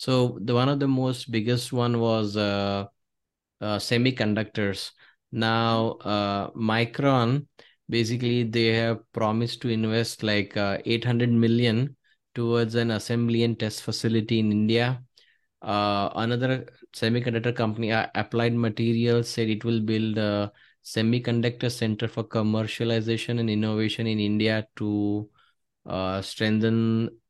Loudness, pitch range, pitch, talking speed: -25 LUFS, 110-120 Hz, 115 Hz, 125 wpm